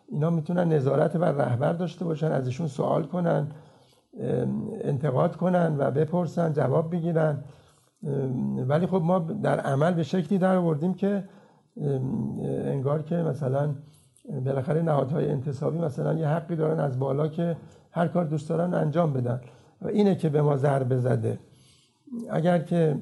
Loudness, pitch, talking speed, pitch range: -26 LUFS, 155 Hz, 140 wpm, 140-170 Hz